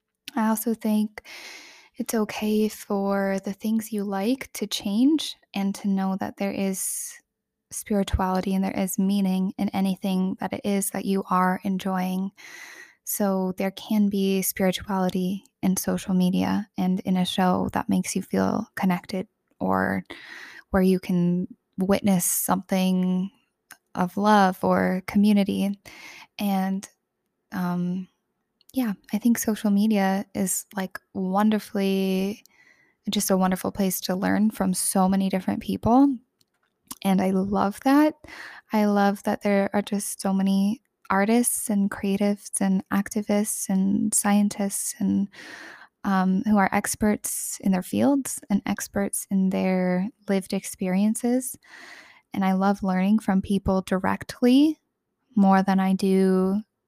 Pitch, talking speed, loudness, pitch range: 195 Hz, 130 wpm, -24 LUFS, 190-215 Hz